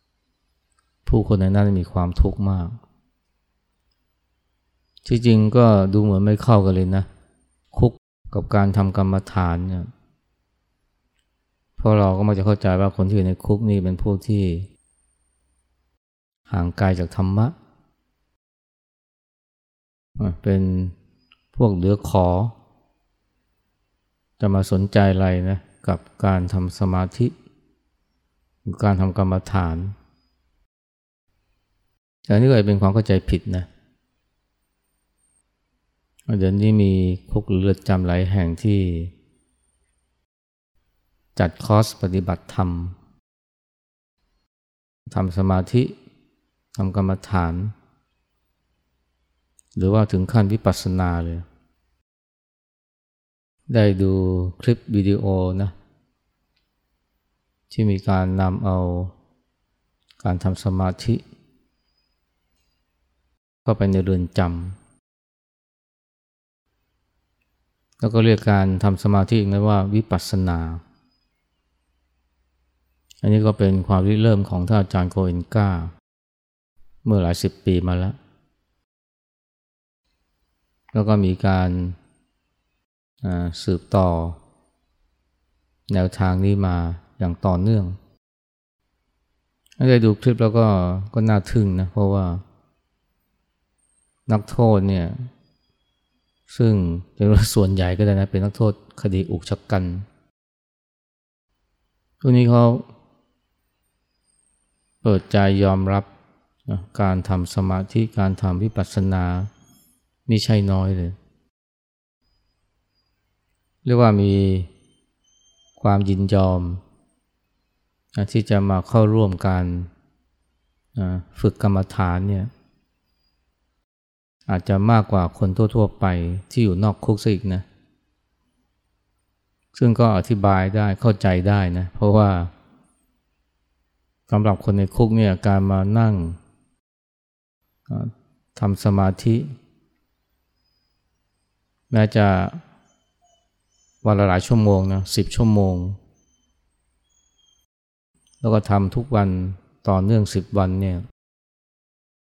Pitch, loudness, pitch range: 95 Hz, -20 LUFS, 80-100 Hz